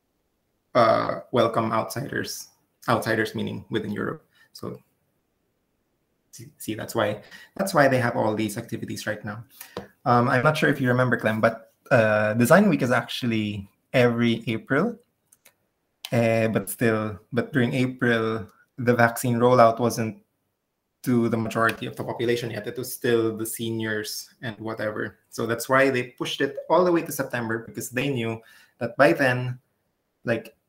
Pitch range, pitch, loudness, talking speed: 110-125 Hz, 115 Hz, -24 LUFS, 155 wpm